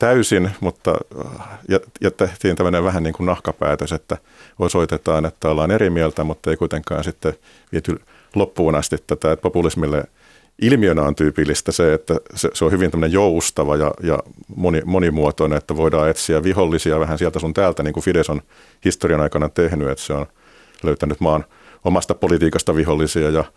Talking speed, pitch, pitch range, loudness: 155 wpm, 80 Hz, 75-90 Hz, -19 LUFS